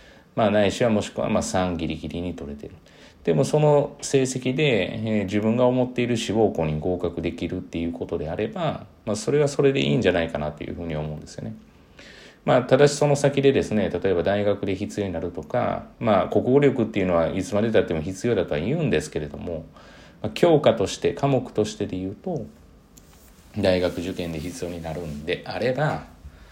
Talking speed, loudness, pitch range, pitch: 395 characters per minute, -23 LUFS, 85-120 Hz, 95 Hz